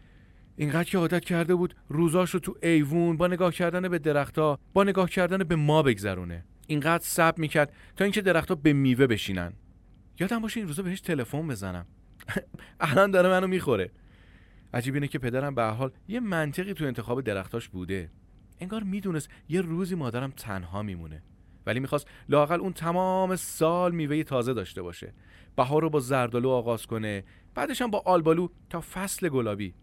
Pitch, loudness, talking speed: 150 Hz, -27 LUFS, 165 wpm